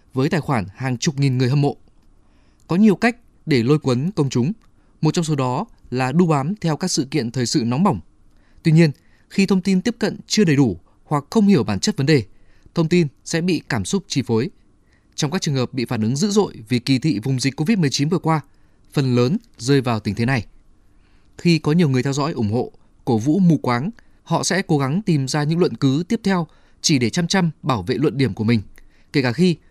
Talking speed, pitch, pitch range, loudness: 235 wpm, 140 Hz, 120-170 Hz, -20 LUFS